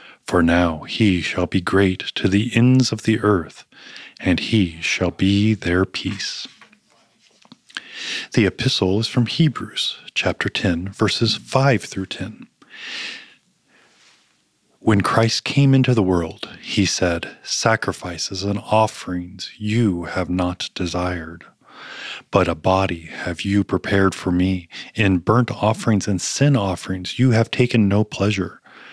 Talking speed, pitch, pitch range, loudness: 130 wpm, 100 Hz, 90-110 Hz, -20 LUFS